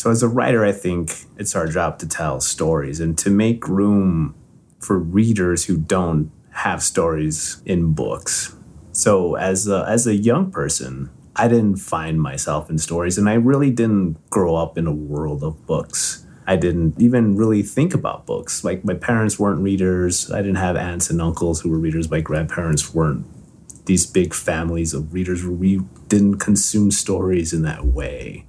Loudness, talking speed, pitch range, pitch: -19 LUFS, 175 wpm, 80-105 Hz, 90 Hz